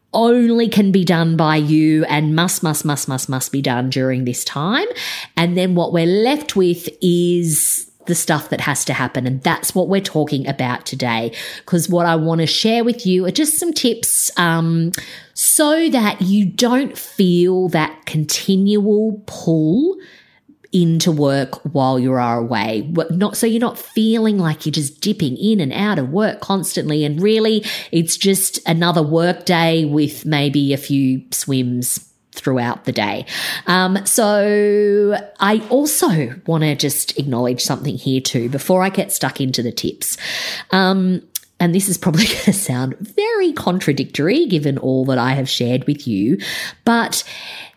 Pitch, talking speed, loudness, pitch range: 170 Hz, 165 wpm, -17 LUFS, 145-205 Hz